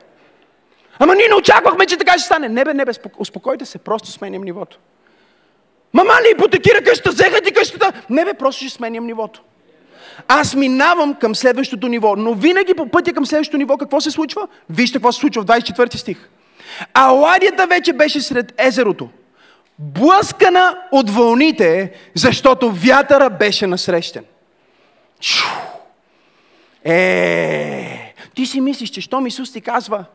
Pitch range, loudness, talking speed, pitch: 230-360 Hz, -14 LUFS, 145 wpm, 270 Hz